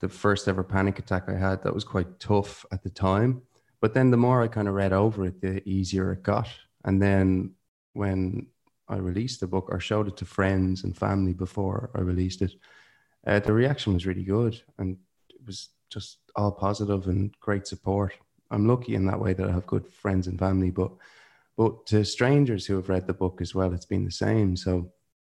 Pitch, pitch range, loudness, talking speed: 95 Hz, 95-105 Hz, -27 LUFS, 210 wpm